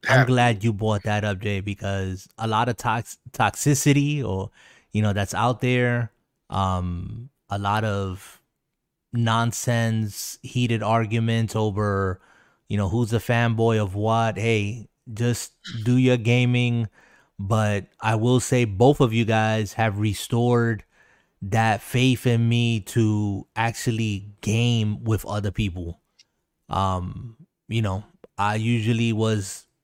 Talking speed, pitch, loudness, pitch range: 130 wpm, 110 Hz, -23 LUFS, 105-120 Hz